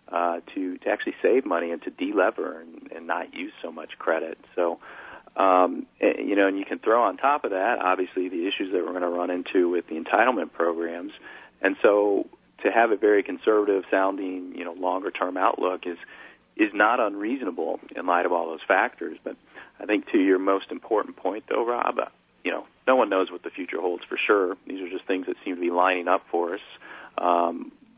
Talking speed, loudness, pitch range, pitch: 215 wpm, -25 LUFS, 90-100 Hz, 95 Hz